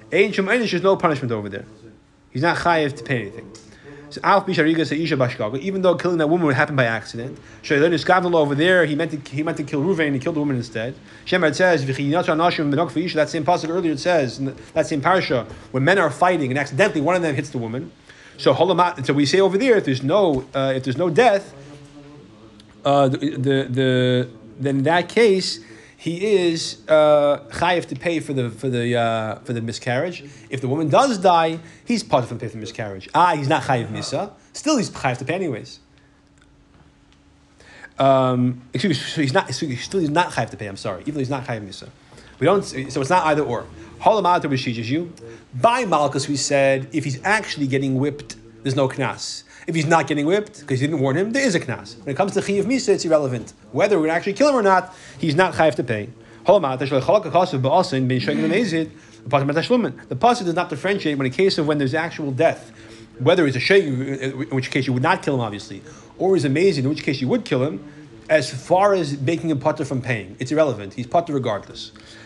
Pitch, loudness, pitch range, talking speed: 145 Hz, -20 LUFS, 130-170 Hz, 205 wpm